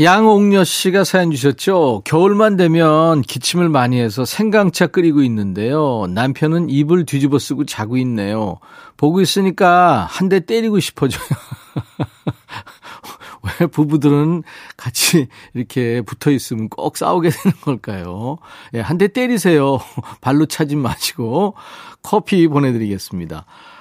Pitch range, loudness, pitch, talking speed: 125-180 Hz, -15 LUFS, 150 Hz, 275 characters per minute